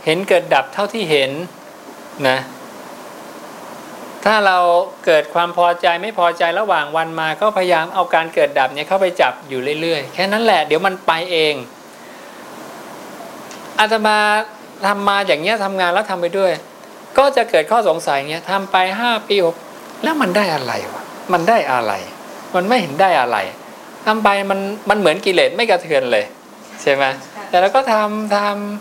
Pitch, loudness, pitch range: 190 Hz, -16 LUFS, 165-210 Hz